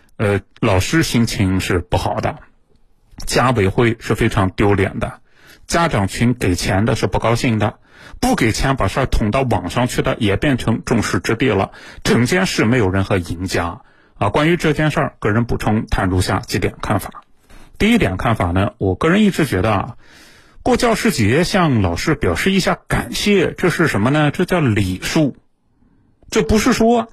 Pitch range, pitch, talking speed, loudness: 100-155 Hz, 115 Hz, 255 characters per minute, -17 LUFS